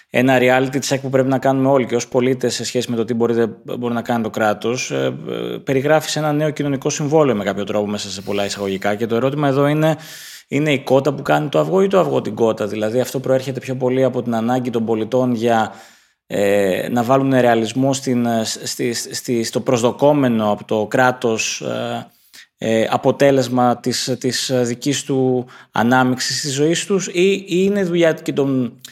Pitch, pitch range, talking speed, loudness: 125 Hz, 115-140 Hz, 195 wpm, -18 LUFS